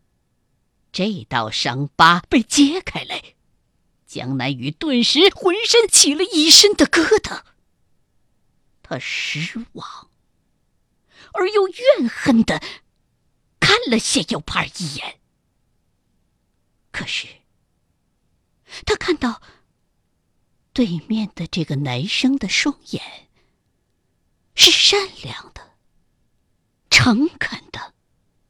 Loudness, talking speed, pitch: -16 LUFS, 125 characters per minute, 255 Hz